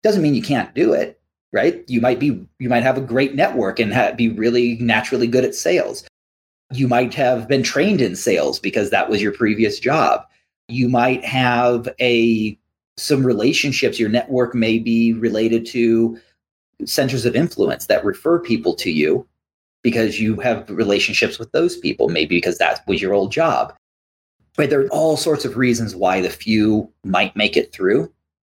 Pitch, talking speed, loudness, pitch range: 120 Hz, 180 wpm, -18 LUFS, 115-130 Hz